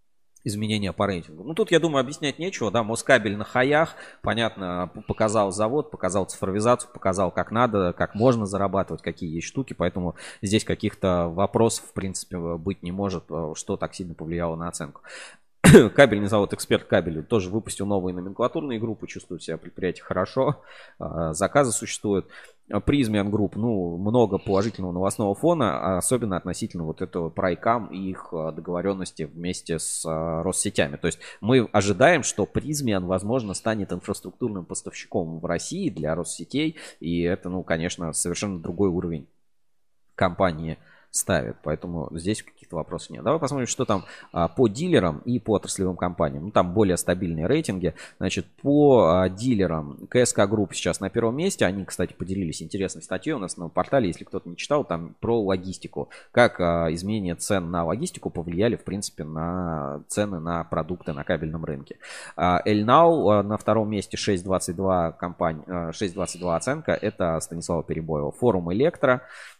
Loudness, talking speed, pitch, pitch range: -24 LUFS, 150 wpm, 95 Hz, 85-110 Hz